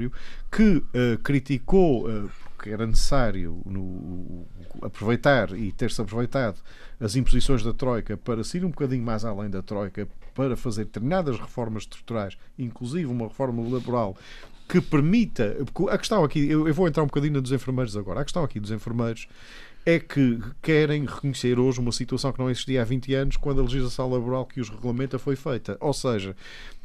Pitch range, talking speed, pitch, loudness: 110-140 Hz, 170 wpm, 125 Hz, -26 LUFS